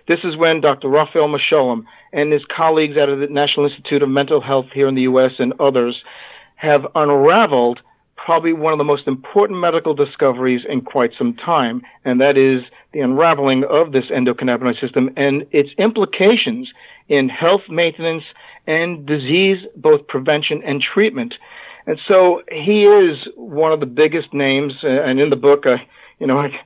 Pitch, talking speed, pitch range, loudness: 145 Hz, 165 wpm, 140-170 Hz, -16 LUFS